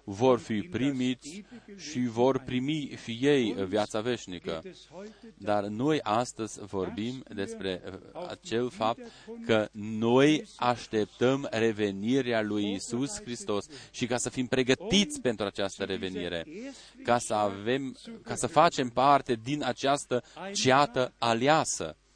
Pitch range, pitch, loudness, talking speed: 105-140 Hz, 125 Hz, -29 LUFS, 115 wpm